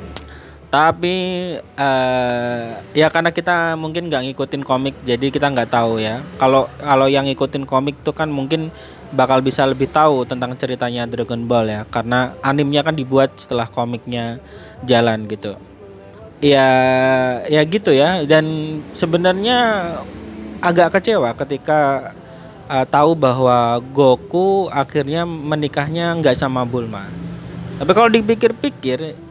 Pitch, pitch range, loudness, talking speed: 135 Hz, 120-155 Hz, -17 LUFS, 125 wpm